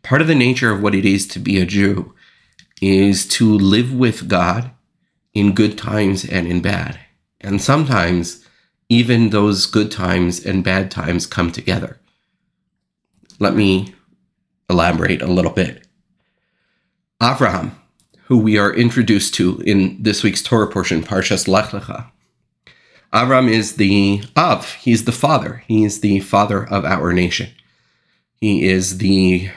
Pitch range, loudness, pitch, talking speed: 95-115 Hz, -16 LUFS, 100 Hz, 140 wpm